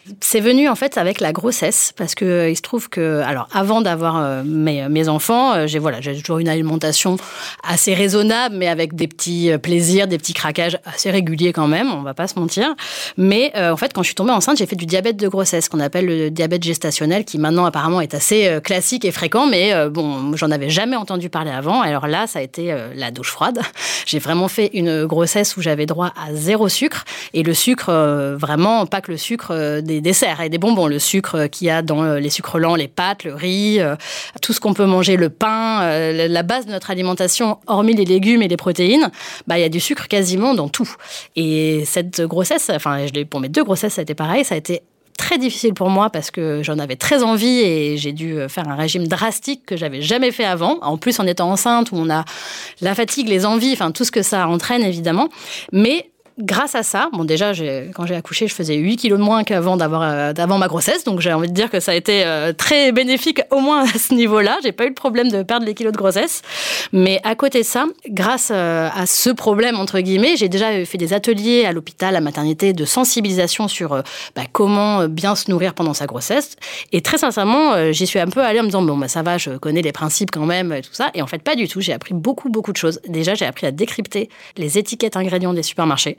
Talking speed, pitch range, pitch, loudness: 240 wpm, 160-220 Hz, 185 Hz, -17 LUFS